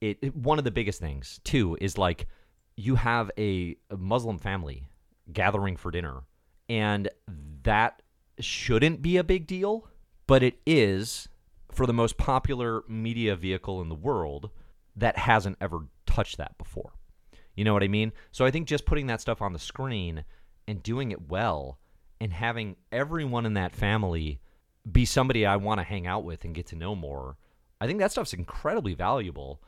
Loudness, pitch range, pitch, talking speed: -28 LUFS, 85-115 Hz, 105 Hz, 180 wpm